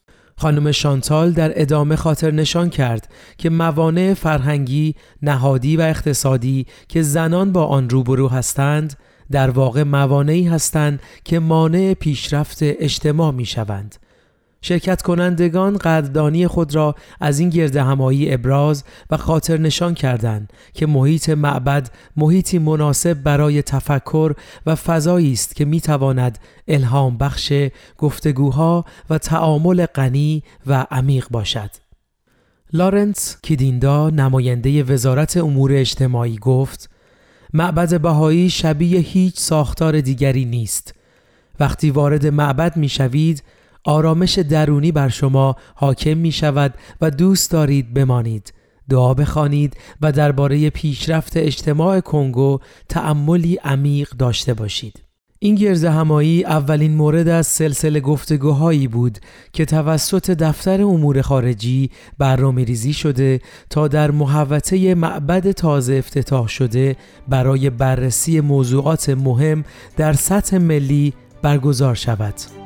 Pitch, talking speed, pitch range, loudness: 150 Hz, 115 wpm, 135-160 Hz, -17 LUFS